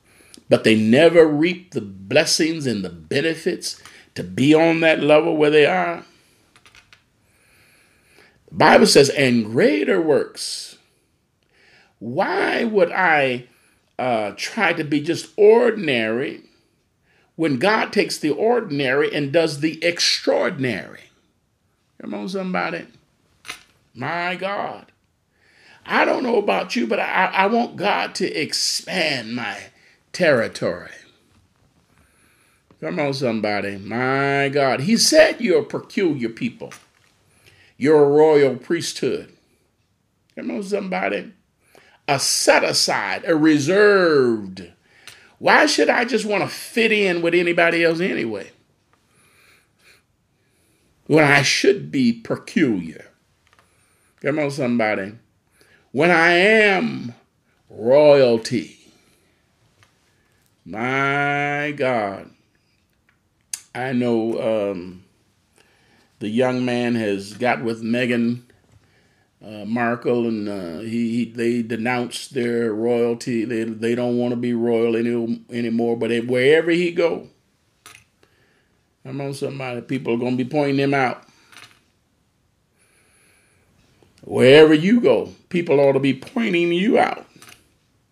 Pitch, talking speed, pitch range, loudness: 130 Hz, 110 wpm, 115-165 Hz, -19 LUFS